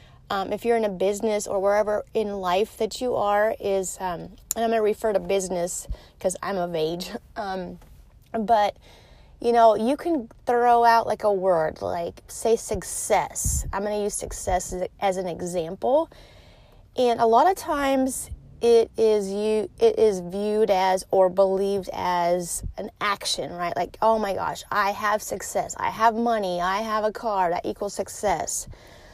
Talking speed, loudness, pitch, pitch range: 175 wpm, -24 LUFS, 210 Hz, 190-230 Hz